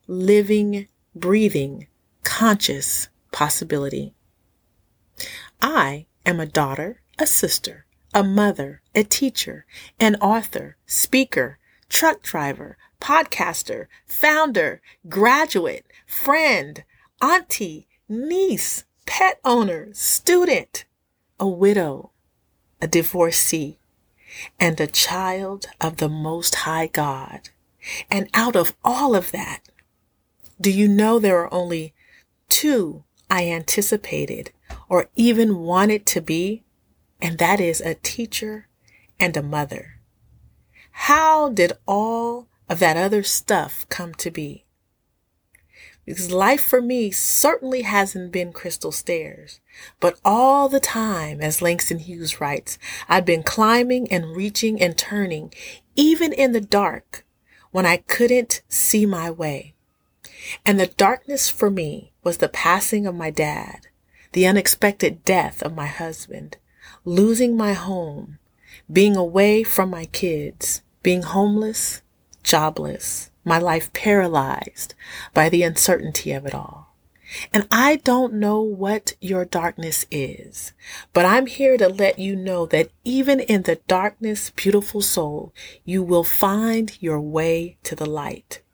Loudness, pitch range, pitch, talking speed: -20 LUFS, 165-225 Hz, 195 Hz, 120 wpm